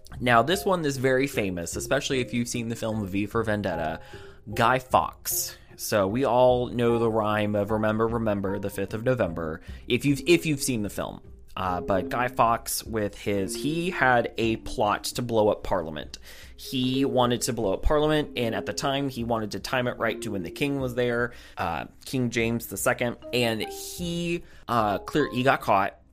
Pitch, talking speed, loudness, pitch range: 120 Hz, 195 wpm, -26 LUFS, 105-130 Hz